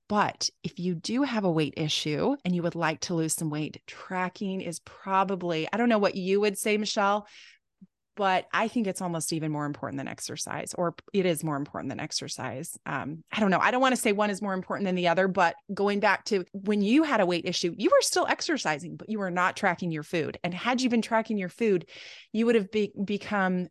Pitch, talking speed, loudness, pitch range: 190 Hz, 235 wpm, -28 LUFS, 170-210 Hz